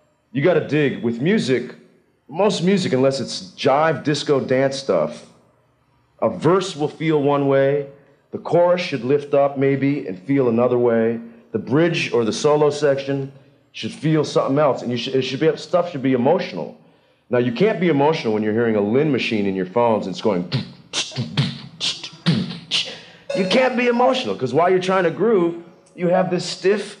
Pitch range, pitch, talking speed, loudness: 130-175 Hz, 145 Hz, 180 wpm, -19 LUFS